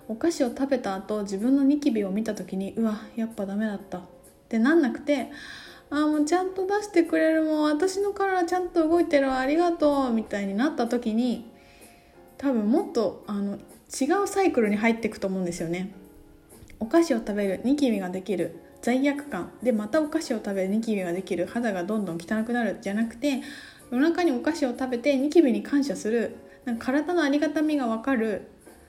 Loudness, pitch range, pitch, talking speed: -26 LUFS, 215-300 Hz, 255 Hz, 385 characters per minute